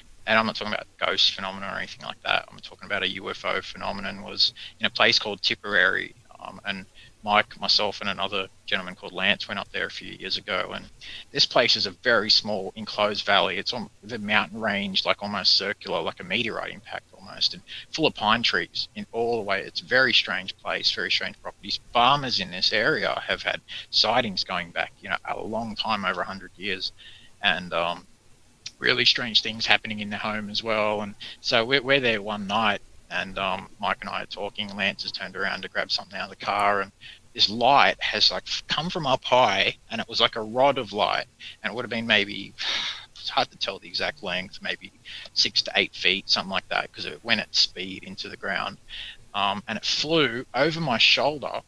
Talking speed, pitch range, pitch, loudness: 210 wpm, 100-115 Hz, 105 Hz, -24 LUFS